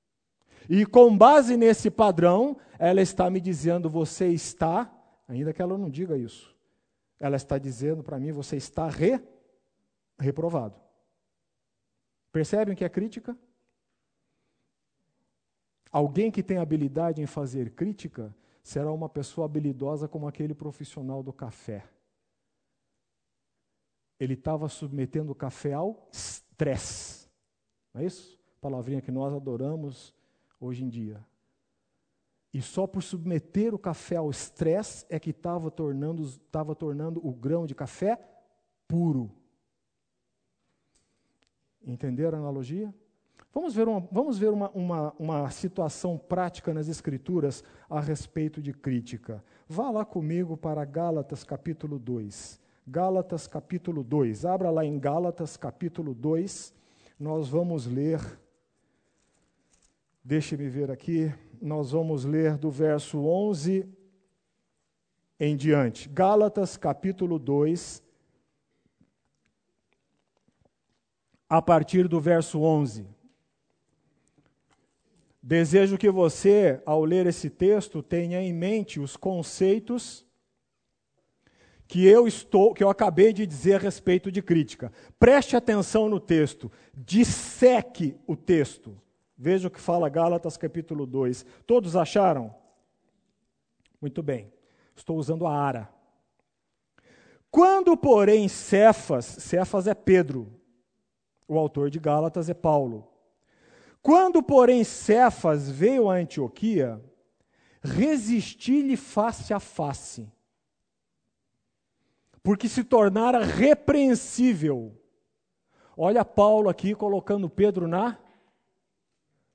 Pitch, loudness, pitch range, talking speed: 165 Hz, -25 LUFS, 145-195 Hz, 110 wpm